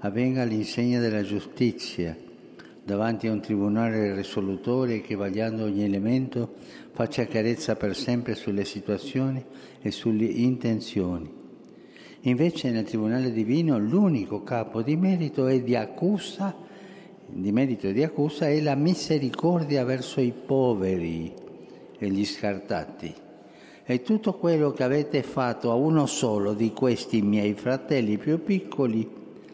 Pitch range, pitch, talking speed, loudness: 105-140 Hz, 120 Hz, 125 wpm, -26 LUFS